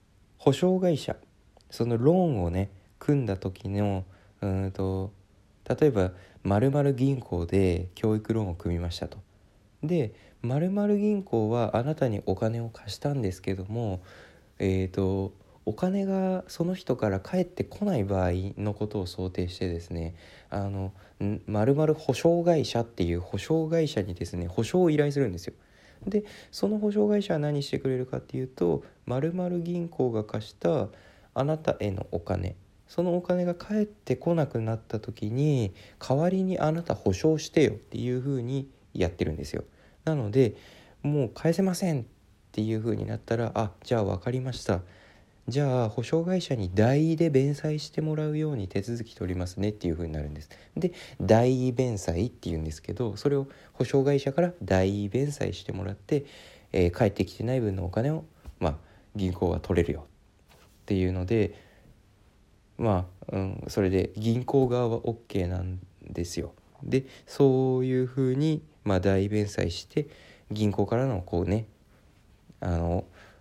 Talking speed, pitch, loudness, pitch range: 305 characters per minute, 110 Hz, -28 LUFS, 95-140 Hz